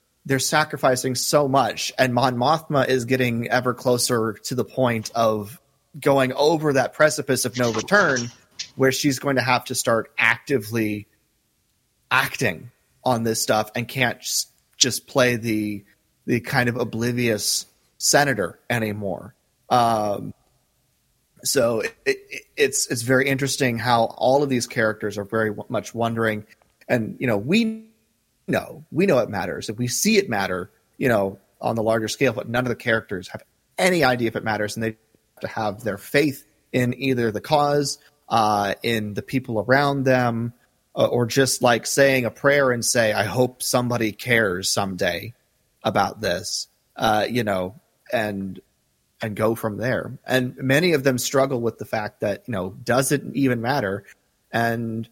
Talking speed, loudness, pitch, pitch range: 165 wpm, -22 LUFS, 120 Hz, 110-135 Hz